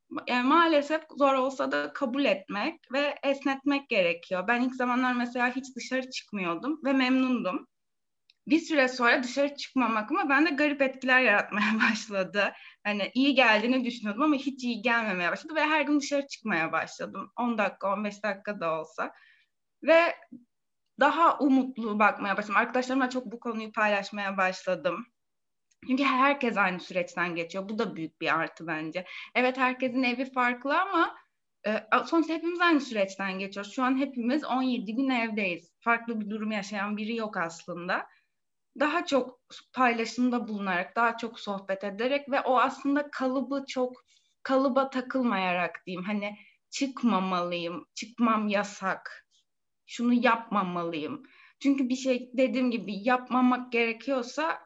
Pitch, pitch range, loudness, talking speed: 245 Hz, 205-275 Hz, -28 LUFS, 140 wpm